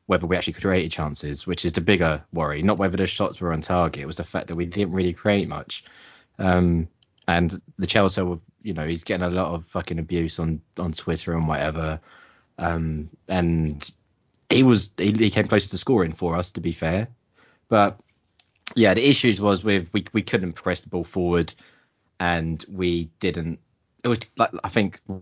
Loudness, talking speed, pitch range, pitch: -23 LUFS, 195 wpm, 85-100 Hz, 90 Hz